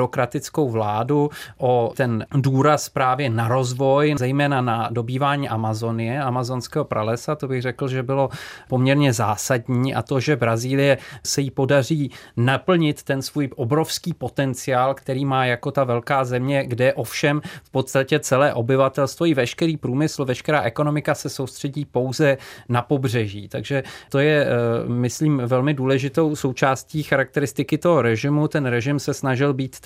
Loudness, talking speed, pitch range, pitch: -21 LUFS, 140 wpm, 125-145 Hz, 135 Hz